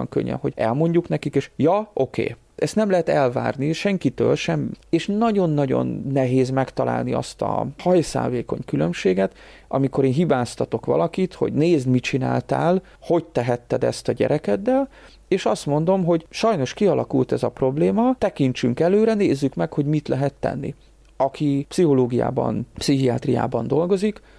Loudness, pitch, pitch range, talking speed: -21 LUFS, 145 Hz, 130-180 Hz, 140 wpm